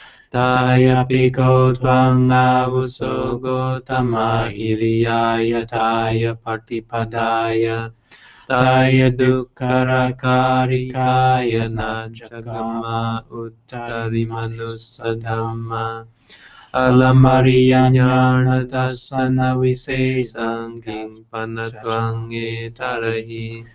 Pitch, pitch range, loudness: 115 Hz, 115-130 Hz, -18 LUFS